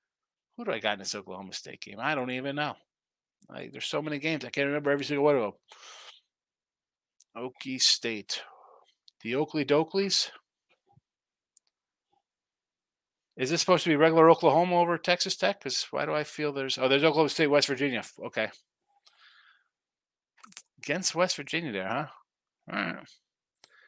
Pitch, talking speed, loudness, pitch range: 150 Hz, 155 wpm, -27 LUFS, 140-170 Hz